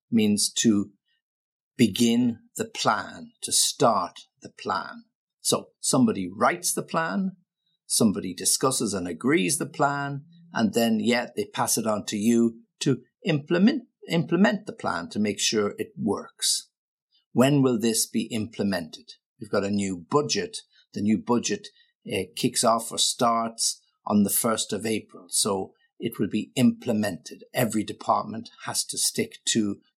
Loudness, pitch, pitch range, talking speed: -25 LUFS, 135 Hz, 115-190 Hz, 150 wpm